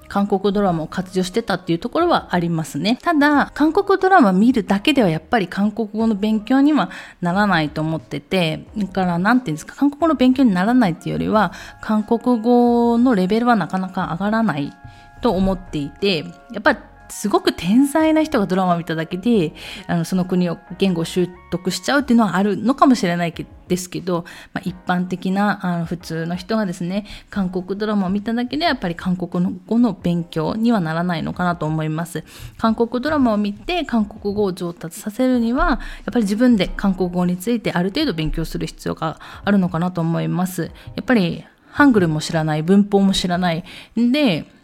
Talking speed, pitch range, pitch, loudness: 390 characters per minute, 175-235 Hz, 195 Hz, -19 LUFS